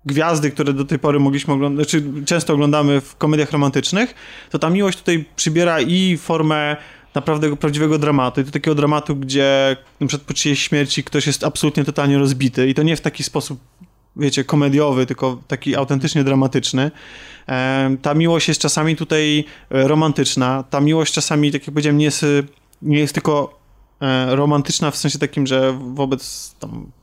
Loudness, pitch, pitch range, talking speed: -17 LUFS, 145 Hz, 140-155 Hz, 165 wpm